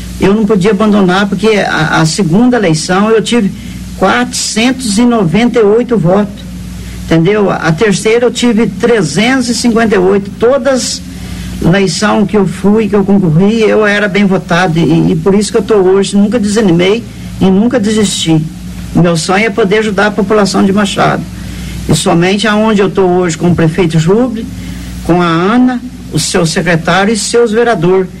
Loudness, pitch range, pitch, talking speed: -9 LUFS, 185-225 Hz, 200 Hz, 155 wpm